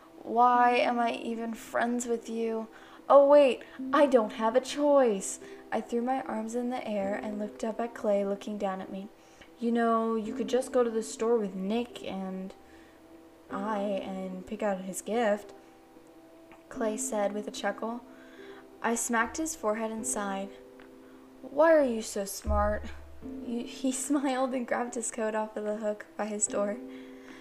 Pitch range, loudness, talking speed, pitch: 195-240 Hz, -29 LUFS, 170 wpm, 220 Hz